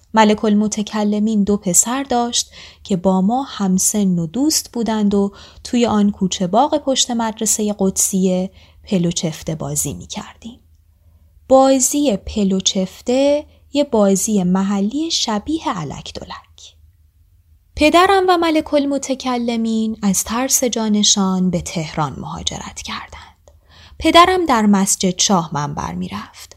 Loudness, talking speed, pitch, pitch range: -16 LUFS, 115 wpm, 210 Hz, 185-250 Hz